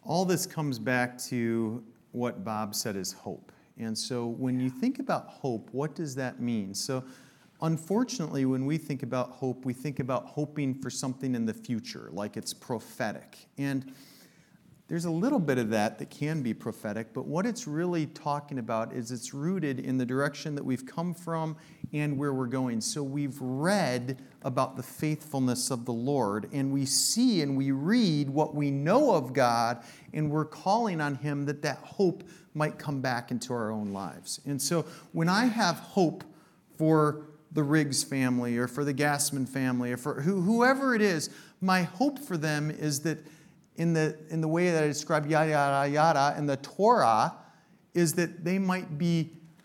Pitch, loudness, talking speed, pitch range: 145 Hz, -29 LUFS, 180 wpm, 130-165 Hz